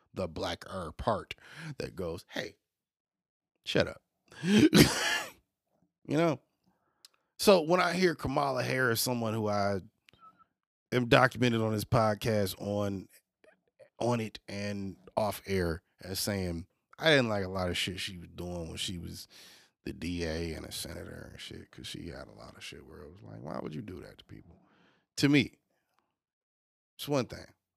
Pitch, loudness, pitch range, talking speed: 100 Hz, -30 LUFS, 90-125 Hz, 165 wpm